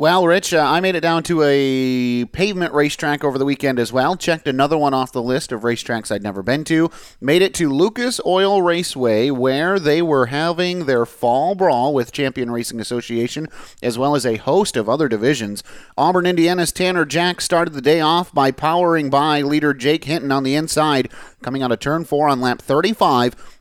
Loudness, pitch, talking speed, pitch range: -18 LUFS, 145 Hz, 200 wpm, 130-170 Hz